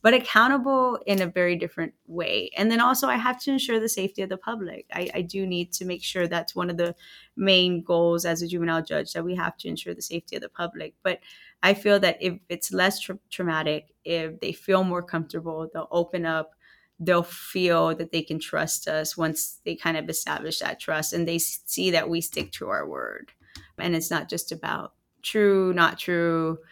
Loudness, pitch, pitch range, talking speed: -25 LUFS, 175 Hz, 165-195 Hz, 210 wpm